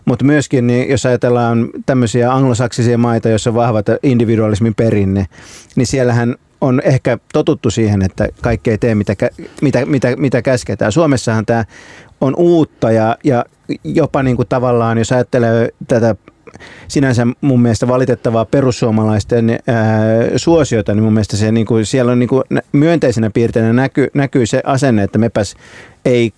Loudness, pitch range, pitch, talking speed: -13 LUFS, 115-130 Hz, 120 Hz, 145 wpm